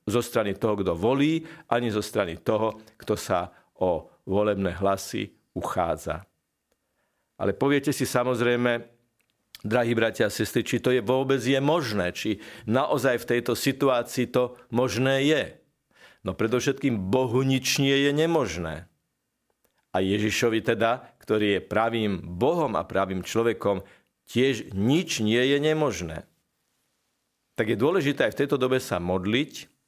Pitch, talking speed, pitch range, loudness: 120 Hz, 135 wpm, 105-130 Hz, -25 LUFS